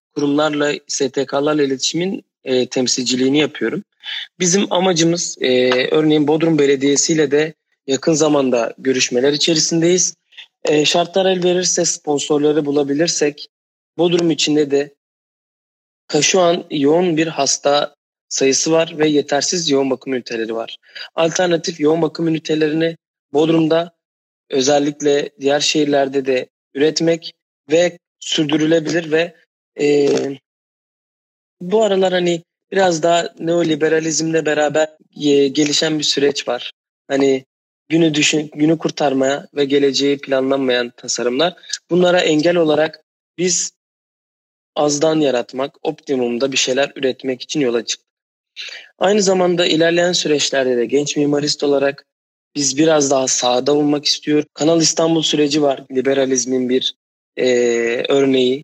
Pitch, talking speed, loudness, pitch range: 150 Hz, 110 wpm, -16 LUFS, 135-165 Hz